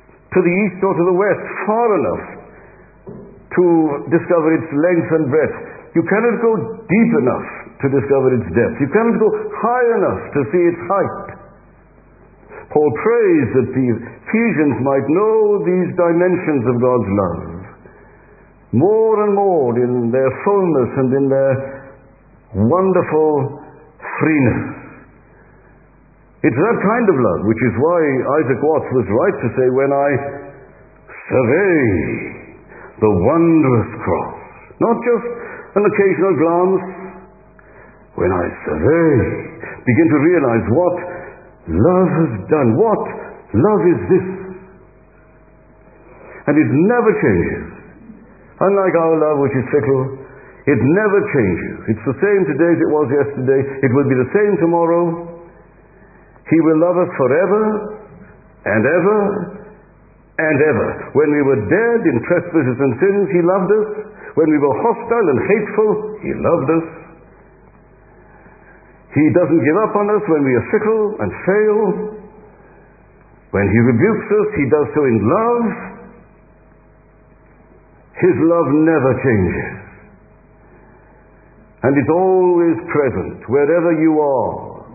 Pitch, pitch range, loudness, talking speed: 170 Hz, 140-205 Hz, -15 LUFS, 130 wpm